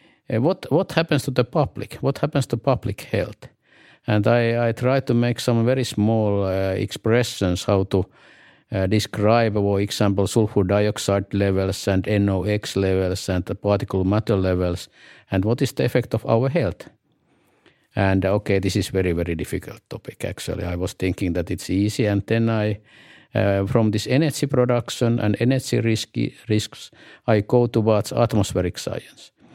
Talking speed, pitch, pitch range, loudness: 160 wpm, 105 Hz, 95-120 Hz, -22 LUFS